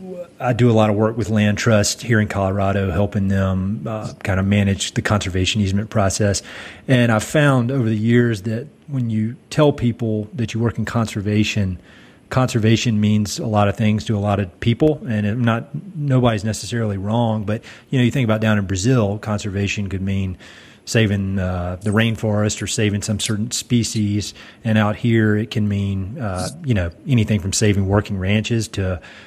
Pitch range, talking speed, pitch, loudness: 100-115 Hz, 190 wpm, 110 Hz, -19 LUFS